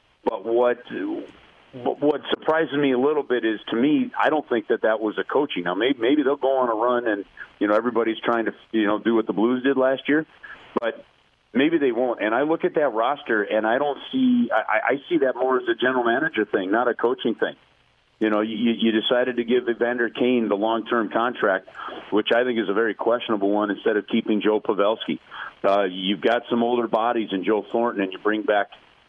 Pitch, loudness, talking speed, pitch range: 120 Hz, -22 LUFS, 225 wpm, 110-130 Hz